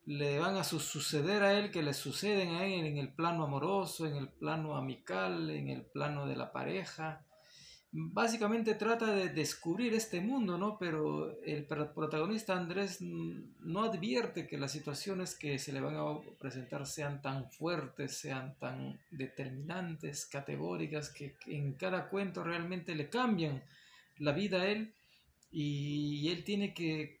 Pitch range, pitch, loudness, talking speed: 145-190 Hz, 160 Hz, -37 LUFS, 150 wpm